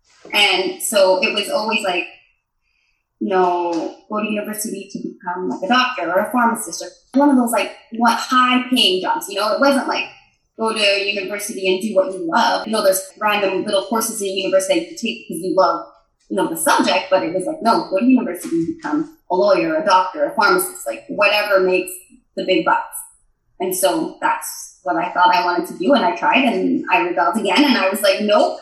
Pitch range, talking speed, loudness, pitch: 190-290 Hz, 215 wpm, -17 LUFS, 220 Hz